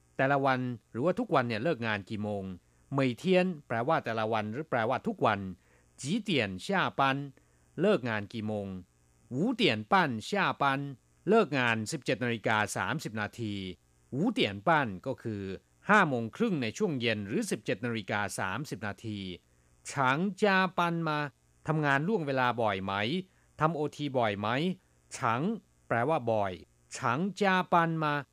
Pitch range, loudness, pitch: 105-155 Hz, -30 LUFS, 125 Hz